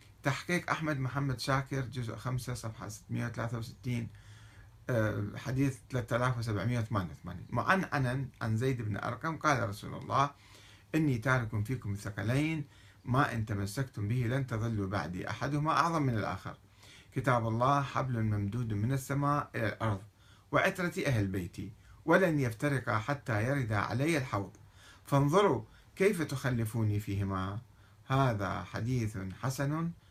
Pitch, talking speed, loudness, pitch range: 120 Hz, 120 wpm, -33 LUFS, 105-140 Hz